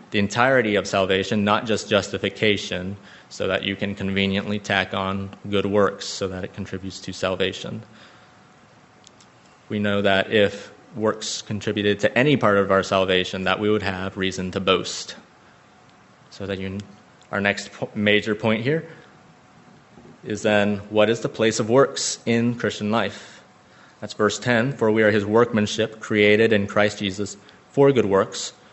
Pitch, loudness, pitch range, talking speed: 105 Hz, -22 LUFS, 100-110 Hz, 155 wpm